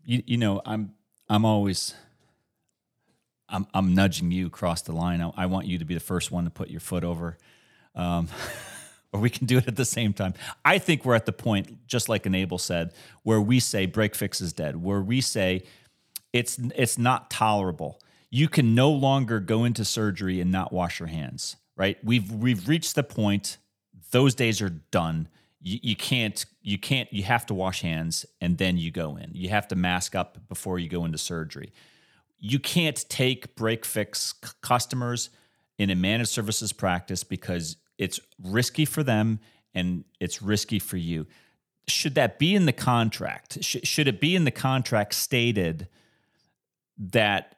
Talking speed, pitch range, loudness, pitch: 180 wpm, 90-120 Hz, -26 LUFS, 105 Hz